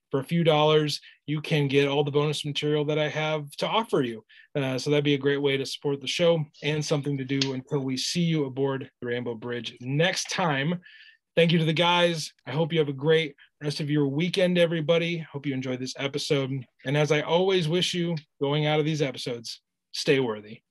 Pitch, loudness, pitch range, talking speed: 150 Hz, -26 LUFS, 140-165 Hz, 220 wpm